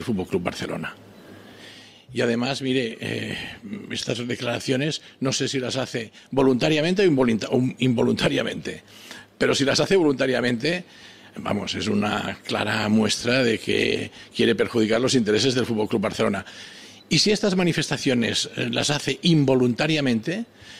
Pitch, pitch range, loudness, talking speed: 130 Hz, 120-145 Hz, -23 LUFS, 135 wpm